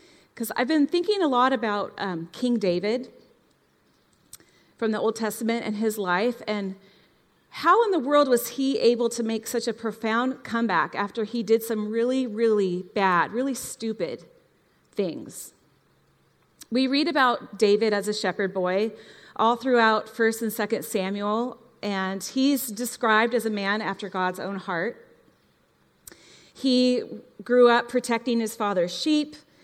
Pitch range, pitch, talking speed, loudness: 205-245 Hz, 225 Hz, 145 wpm, -25 LUFS